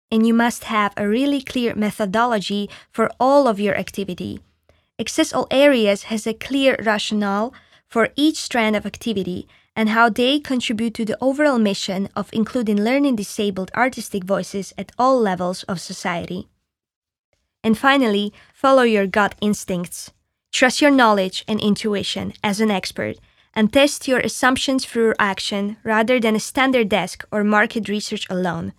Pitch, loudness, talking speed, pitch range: 220 Hz, -19 LUFS, 150 wpm, 200-245 Hz